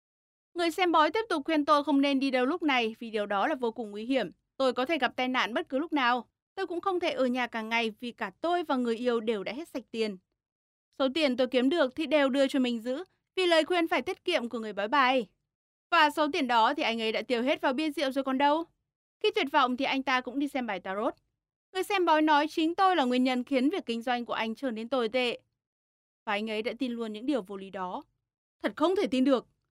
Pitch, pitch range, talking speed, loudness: 265 Hz, 235-310 Hz, 270 wpm, -28 LUFS